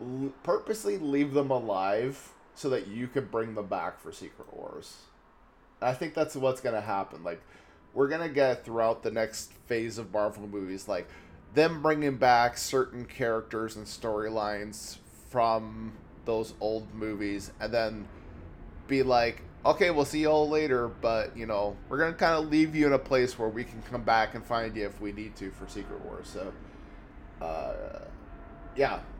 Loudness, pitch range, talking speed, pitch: -30 LUFS, 105-135 Hz, 170 wpm, 115 Hz